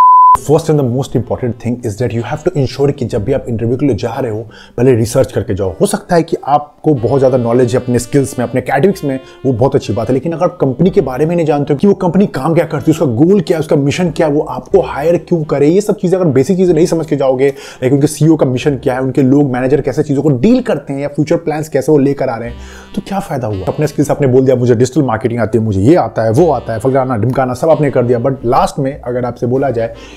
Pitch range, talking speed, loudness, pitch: 125-160 Hz, 290 wpm, -12 LUFS, 140 Hz